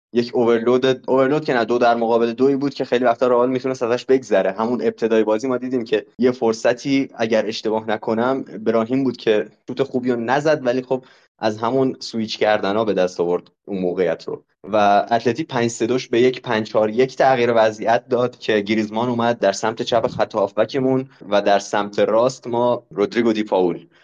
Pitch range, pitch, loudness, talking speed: 110-130 Hz, 120 Hz, -19 LUFS, 185 wpm